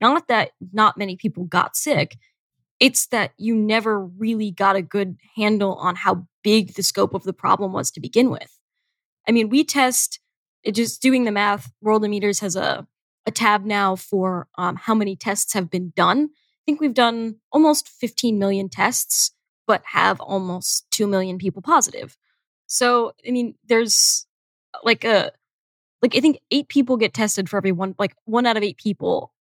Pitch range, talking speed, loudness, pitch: 195-240 Hz, 180 wpm, -20 LUFS, 210 Hz